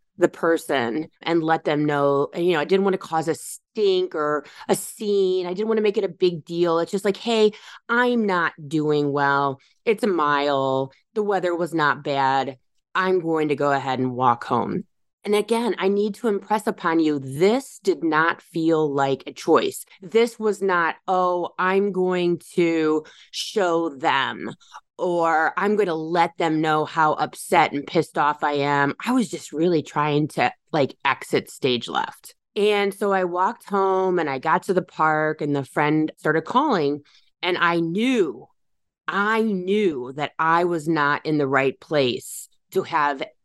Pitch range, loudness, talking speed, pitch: 150-195 Hz, -22 LUFS, 180 wpm, 170 Hz